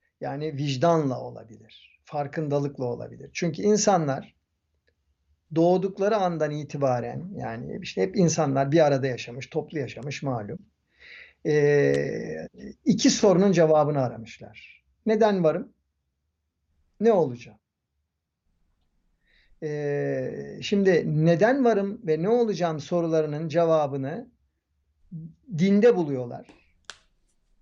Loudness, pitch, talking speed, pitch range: -24 LUFS, 145 Hz, 85 wpm, 110-170 Hz